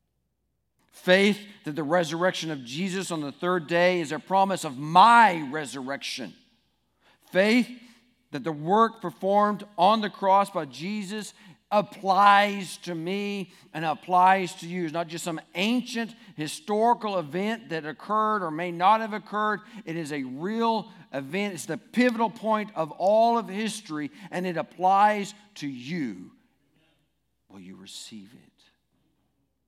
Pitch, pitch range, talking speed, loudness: 185 Hz, 165-210 Hz, 140 wpm, -25 LUFS